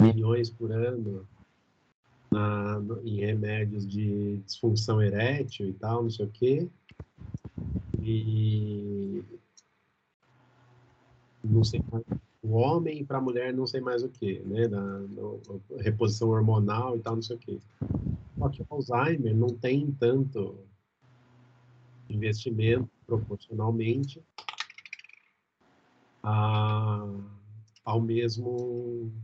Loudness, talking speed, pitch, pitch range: -30 LUFS, 110 wpm, 115 Hz, 105-125 Hz